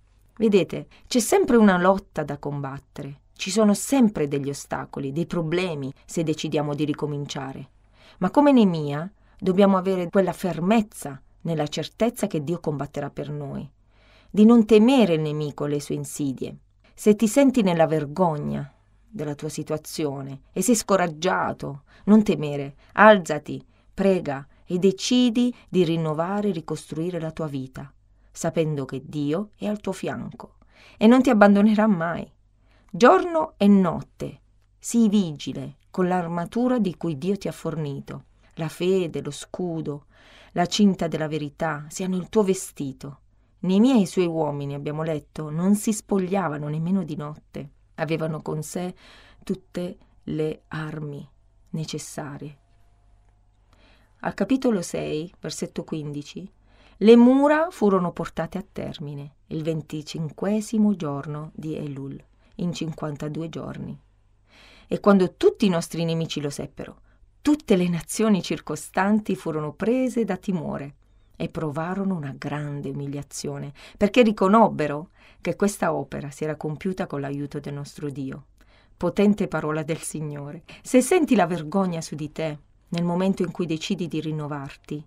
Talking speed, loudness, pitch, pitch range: 135 wpm, -23 LUFS, 160 Hz, 145-195 Hz